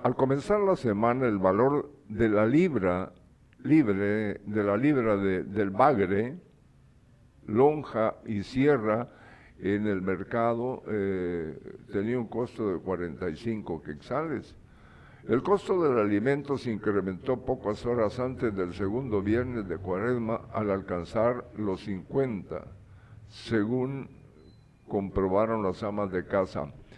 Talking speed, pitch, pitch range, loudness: 120 wpm, 105 Hz, 95-125 Hz, -28 LUFS